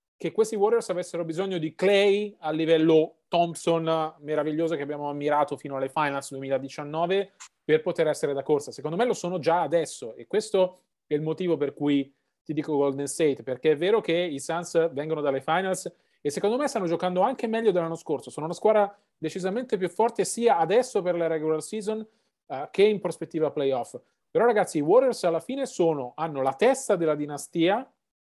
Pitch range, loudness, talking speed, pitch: 150-200 Hz, -26 LUFS, 185 wpm, 165 Hz